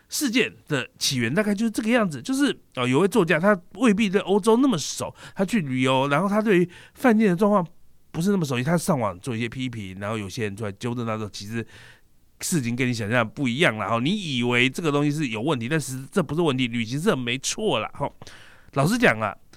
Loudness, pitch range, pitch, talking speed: -23 LUFS, 120-200 Hz, 145 Hz, 335 characters per minute